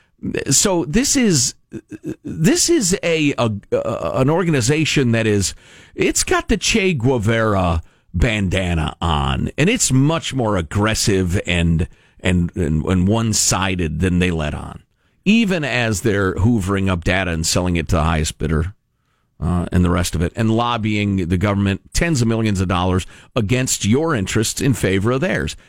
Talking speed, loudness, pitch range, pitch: 160 wpm, -18 LUFS, 90-130 Hz, 105 Hz